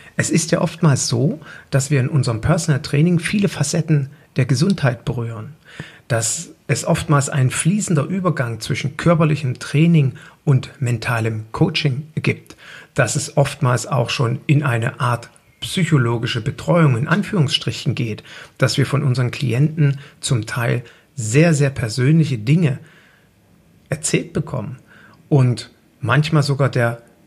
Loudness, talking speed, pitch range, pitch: -19 LUFS, 130 wpm, 125-160 Hz, 140 Hz